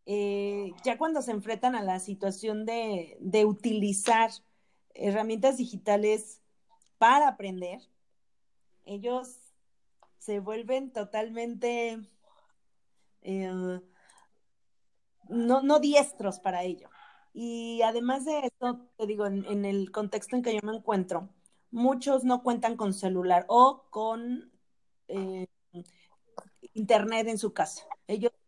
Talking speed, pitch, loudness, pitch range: 110 wpm, 220 Hz, -29 LUFS, 200-245 Hz